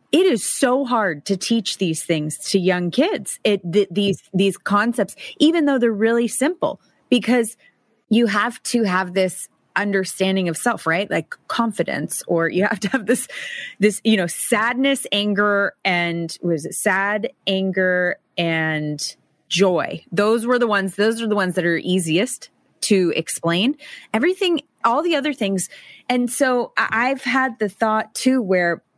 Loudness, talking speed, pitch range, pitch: -20 LUFS, 160 wpm, 180-245 Hz, 205 Hz